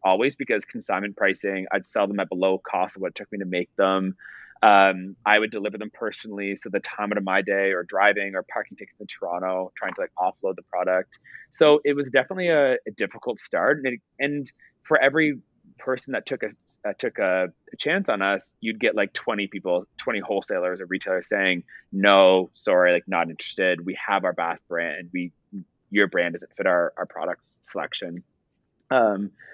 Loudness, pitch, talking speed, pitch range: -24 LUFS, 95 Hz, 195 wpm, 95-105 Hz